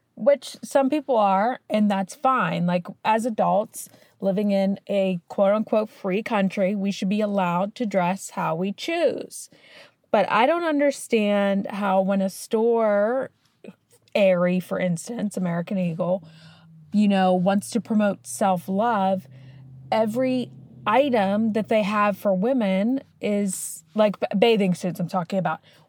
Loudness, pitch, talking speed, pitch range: -23 LUFS, 200 Hz, 140 wpm, 185-220 Hz